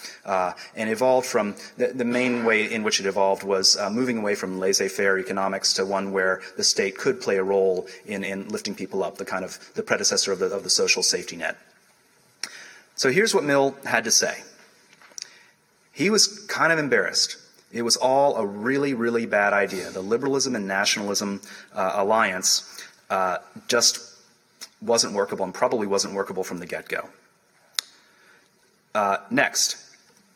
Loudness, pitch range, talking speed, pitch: -23 LUFS, 95-135 Hz, 165 wpm, 105 Hz